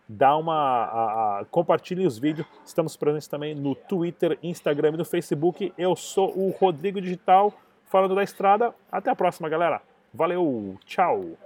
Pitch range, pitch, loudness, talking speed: 160-190 Hz, 175 Hz, -25 LUFS, 145 wpm